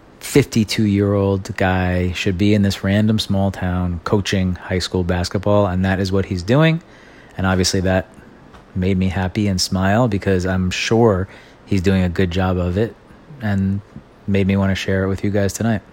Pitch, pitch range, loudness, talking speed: 95 Hz, 95-105 Hz, -18 LUFS, 190 wpm